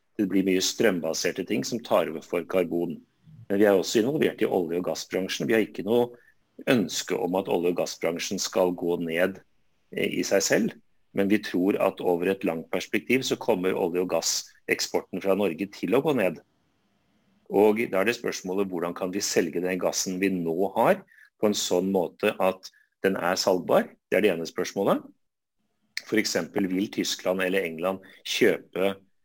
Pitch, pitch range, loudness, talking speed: 95 Hz, 90-105 Hz, -26 LUFS, 180 wpm